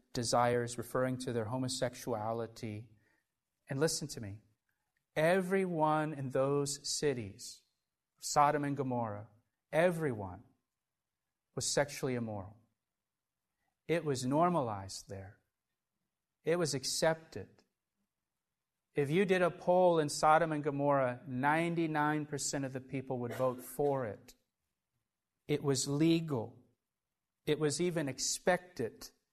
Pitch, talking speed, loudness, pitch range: 140 Hz, 105 wpm, -34 LUFS, 120-155 Hz